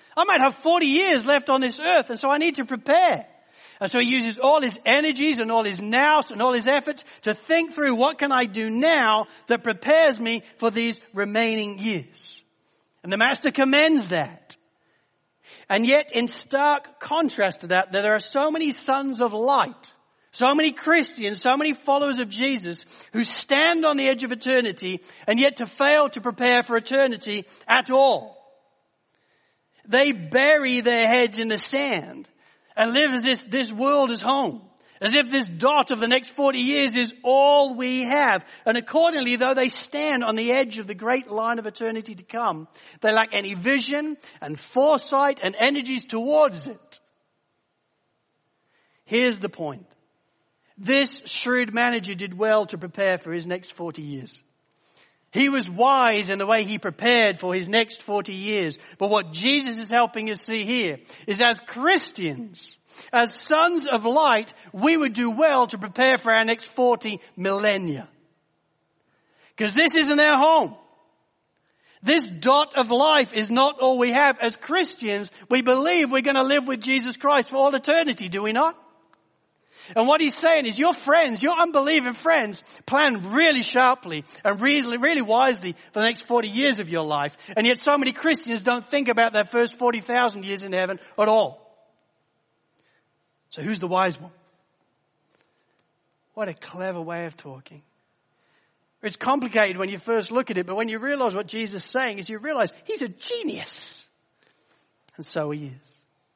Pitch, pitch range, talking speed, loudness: 245 Hz, 210-280 Hz, 175 wpm, -21 LUFS